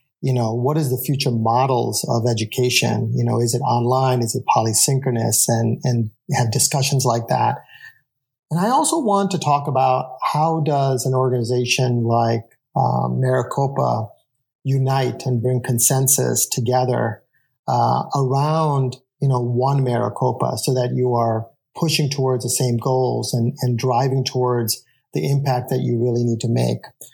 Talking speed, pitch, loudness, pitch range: 155 wpm, 125 Hz, -19 LUFS, 120-135 Hz